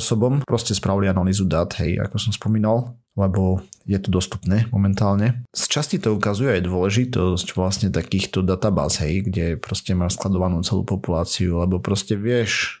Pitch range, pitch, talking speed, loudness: 90-110 Hz, 100 Hz, 155 wpm, -21 LUFS